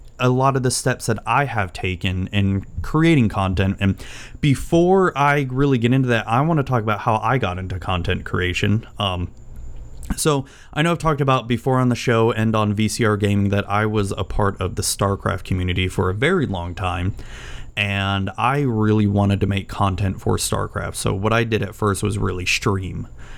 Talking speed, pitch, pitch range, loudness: 200 wpm, 105 Hz, 95-125 Hz, -20 LUFS